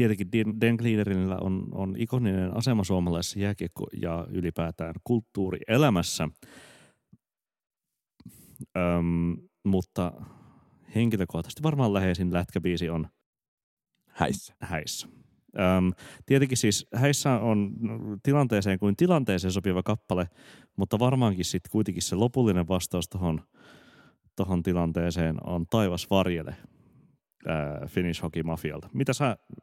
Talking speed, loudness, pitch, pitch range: 95 wpm, -28 LUFS, 95 Hz, 85-110 Hz